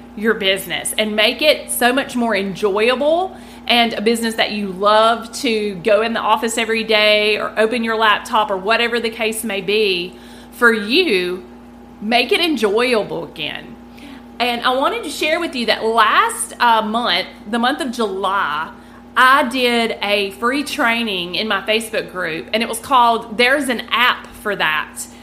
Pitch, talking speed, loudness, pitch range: 225 Hz, 170 wpm, -16 LUFS, 210-245 Hz